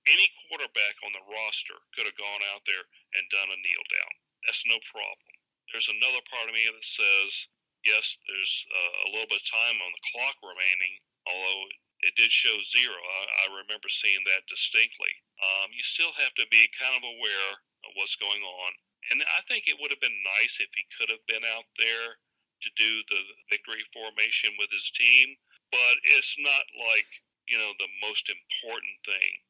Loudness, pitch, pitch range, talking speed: -25 LUFS, 110 Hz, 95-115 Hz, 185 wpm